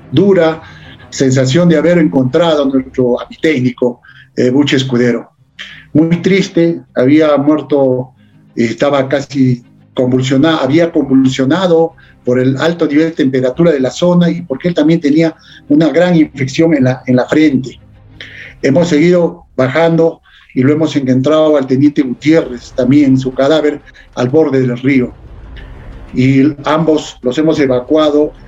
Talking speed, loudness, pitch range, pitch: 135 wpm, -11 LUFS, 130-160 Hz, 145 Hz